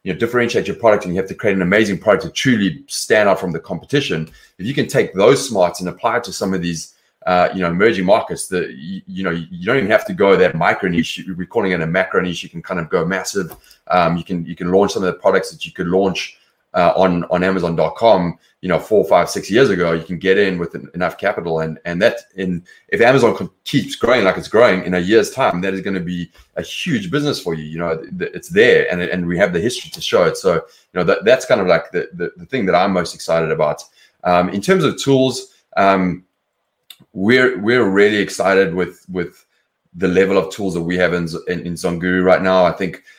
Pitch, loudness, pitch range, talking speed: 95 Hz, -17 LUFS, 85-100 Hz, 250 wpm